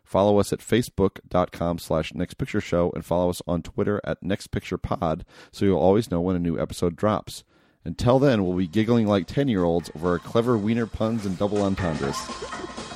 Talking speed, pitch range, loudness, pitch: 170 wpm, 85-105 Hz, -24 LUFS, 95 Hz